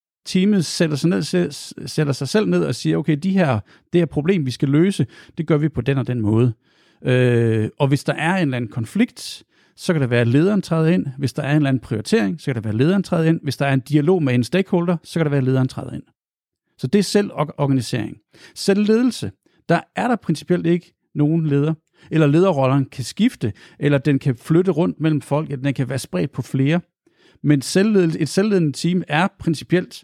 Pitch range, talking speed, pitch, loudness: 135-180 Hz, 220 wpm, 155 Hz, -19 LUFS